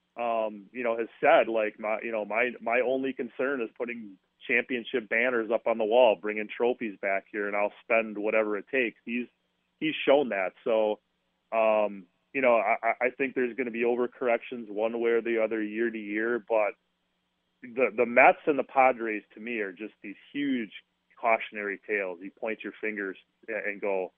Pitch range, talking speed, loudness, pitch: 105-120 Hz, 190 wpm, -28 LUFS, 115 Hz